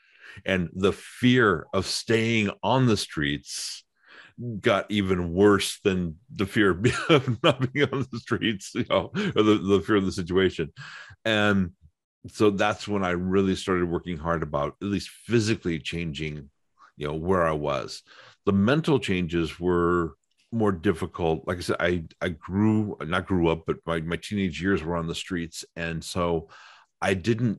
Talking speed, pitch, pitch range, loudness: 165 wpm, 95 Hz, 85-105 Hz, -25 LUFS